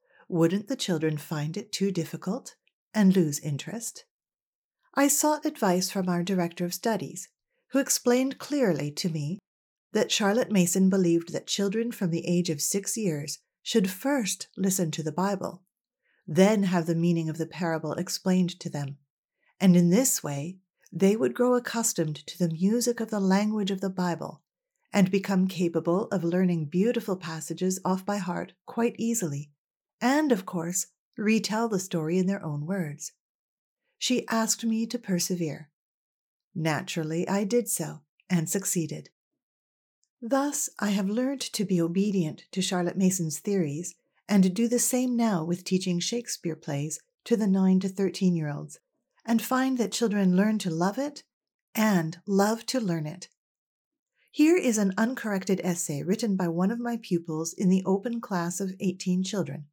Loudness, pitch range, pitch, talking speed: -27 LUFS, 170-225 Hz, 190 Hz, 160 wpm